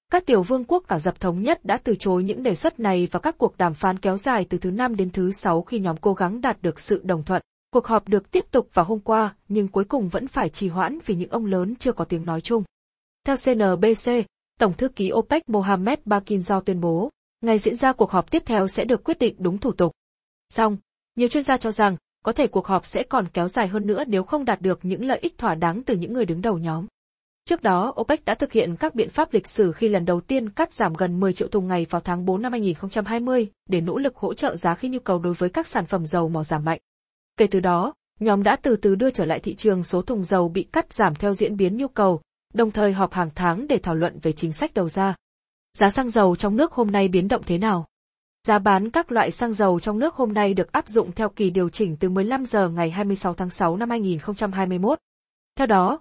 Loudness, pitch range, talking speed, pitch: -23 LUFS, 185-235 Hz, 255 wpm, 205 Hz